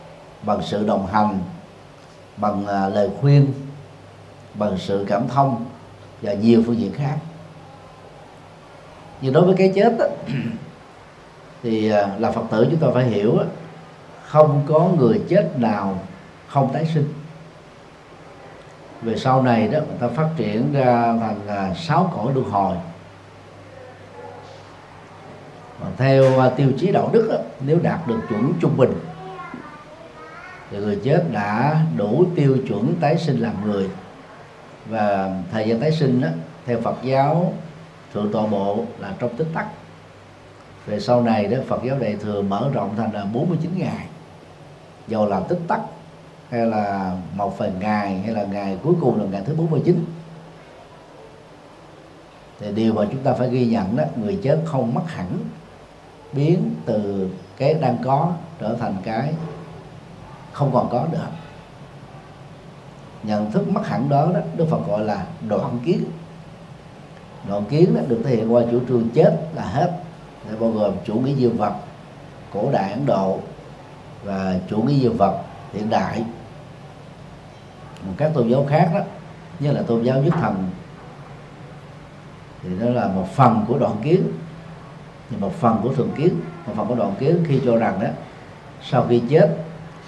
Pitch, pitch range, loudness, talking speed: 135 Hz, 110-155 Hz, -20 LUFS, 155 wpm